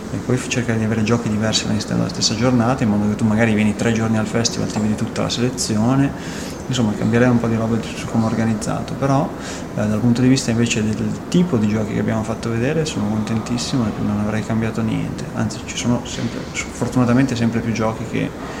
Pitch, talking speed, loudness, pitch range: 115 Hz, 225 wpm, -19 LUFS, 110-120 Hz